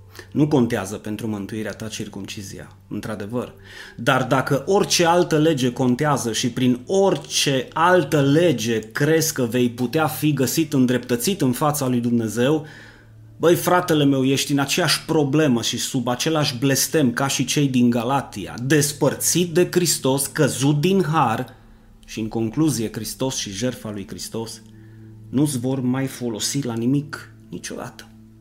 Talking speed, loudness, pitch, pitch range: 140 wpm, -20 LUFS, 125 Hz, 110-150 Hz